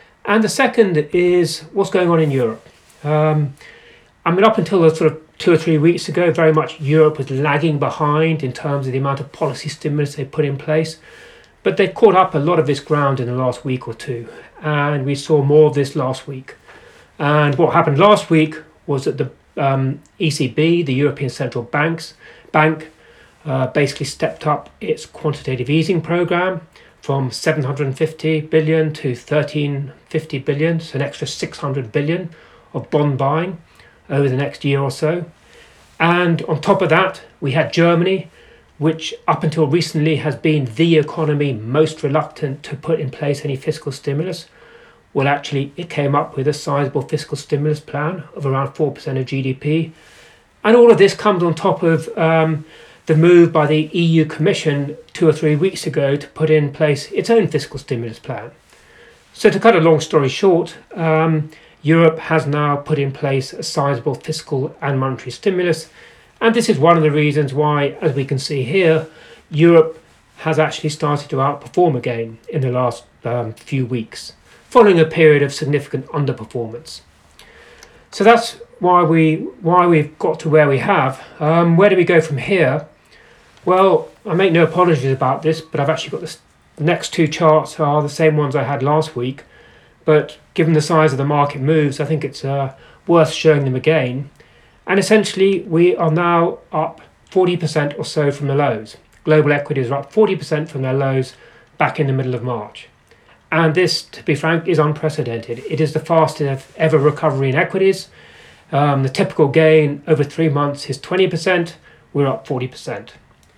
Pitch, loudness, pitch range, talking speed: 155 Hz, -17 LUFS, 140-165 Hz, 180 wpm